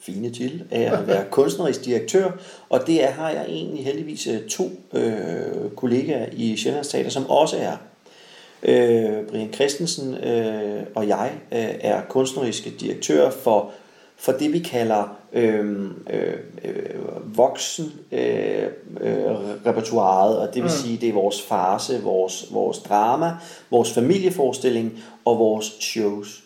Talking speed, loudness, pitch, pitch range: 130 wpm, -22 LUFS, 120 Hz, 105-155 Hz